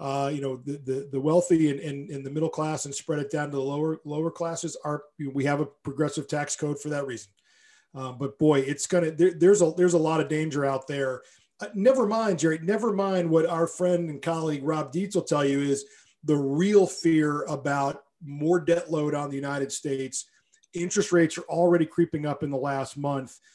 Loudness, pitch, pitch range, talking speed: -26 LUFS, 155 Hz, 140-170 Hz, 220 wpm